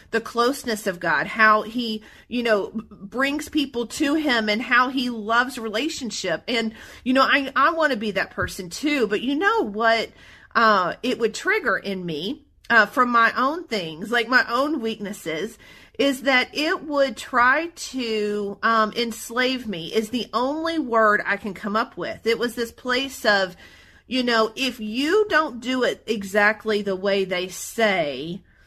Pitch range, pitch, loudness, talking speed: 215-260 Hz, 230 Hz, -22 LUFS, 170 wpm